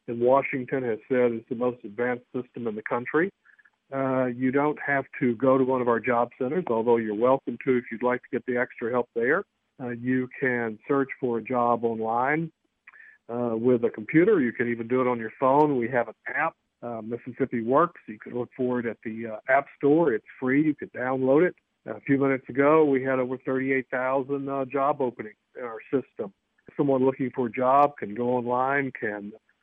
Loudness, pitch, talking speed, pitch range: -26 LUFS, 125 Hz, 215 wpm, 120-135 Hz